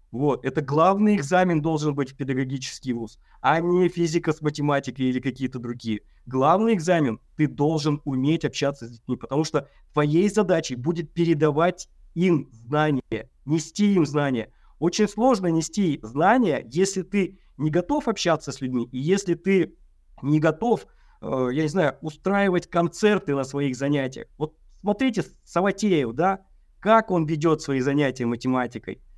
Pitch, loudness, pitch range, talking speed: 155 Hz, -24 LUFS, 135-180 Hz, 145 wpm